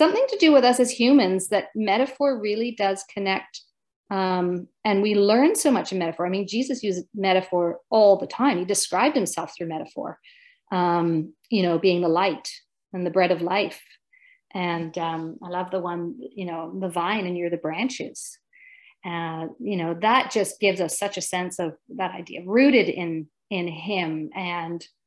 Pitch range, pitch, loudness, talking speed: 175-235 Hz, 190 Hz, -23 LUFS, 180 wpm